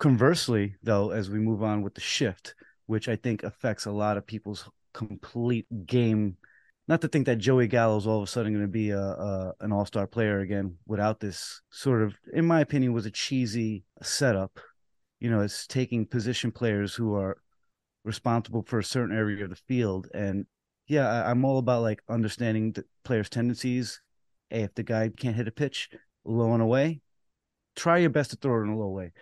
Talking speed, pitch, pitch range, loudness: 205 wpm, 110 Hz, 105-120 Hz, -28 LUFS